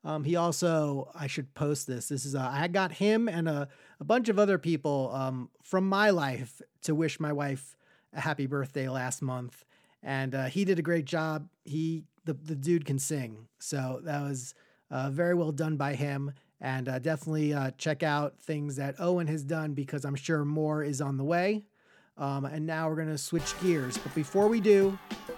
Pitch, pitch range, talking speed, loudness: 150 Hz, 140-170 Hz, 200 wpm, -31 LUFS